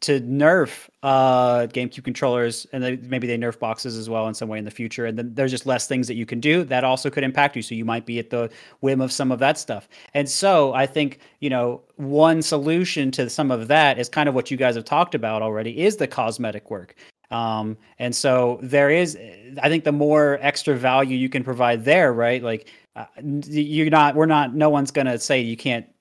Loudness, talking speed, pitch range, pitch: -21 LUFS, 230 wpm, 120-145 Hz, 130 Hz